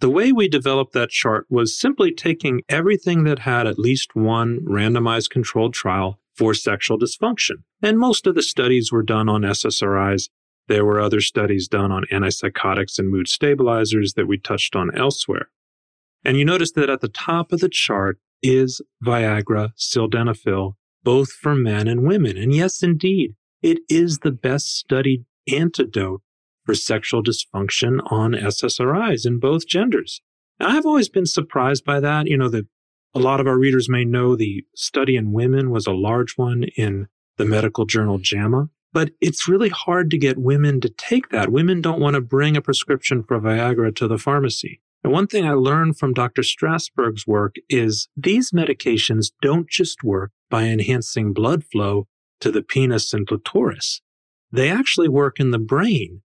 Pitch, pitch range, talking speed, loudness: 125 Hz, 110-150 Hz, 175 wpm, -19 LUFS